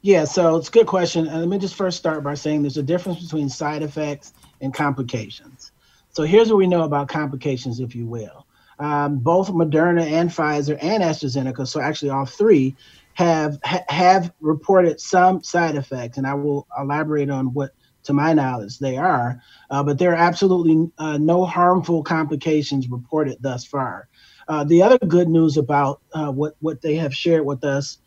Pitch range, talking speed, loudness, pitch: 140-170 Hz, 185 wpm, -20 LUFS, 150 Hz